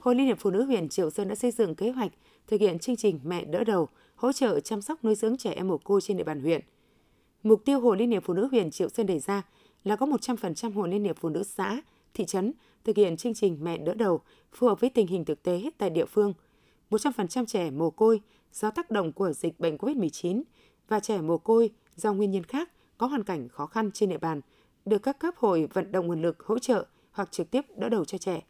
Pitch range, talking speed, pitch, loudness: 180-230 Hz, 250 wpm, 205 Hz, -28 LUFS